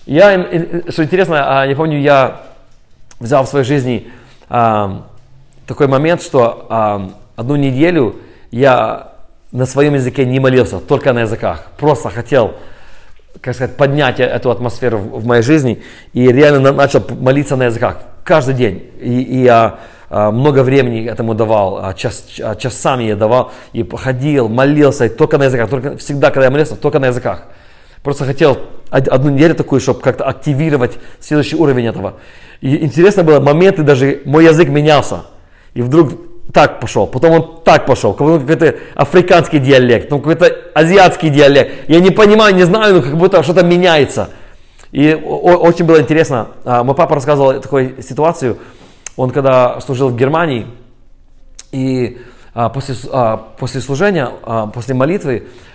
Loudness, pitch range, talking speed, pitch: -12 LUFS, 120-155 Hz, 140 wpm, 135 Hz